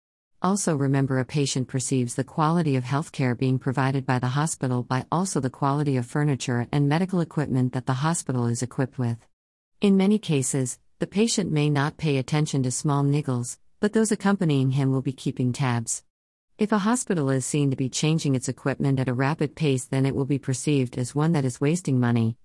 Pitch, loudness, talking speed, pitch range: 135 Hz, -25 LUFS, 200 wpm, 130-150 Hz